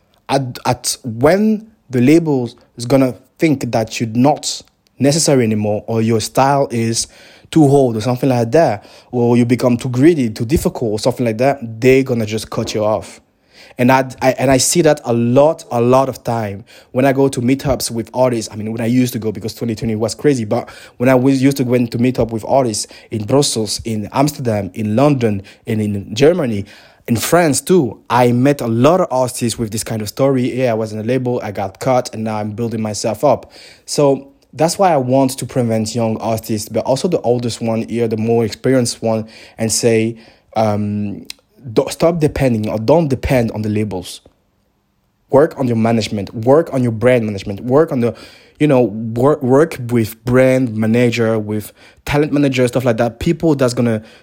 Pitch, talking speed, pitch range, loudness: 120 Hz, 200 wpm, 110-130 Hz, -15 LUFS